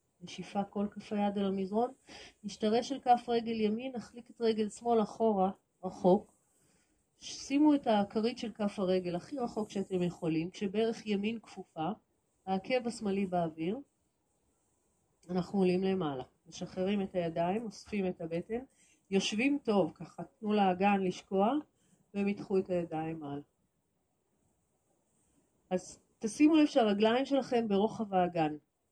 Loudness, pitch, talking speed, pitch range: -33 LUFS, 200 Hz, 120 wpm, 180-225 Hz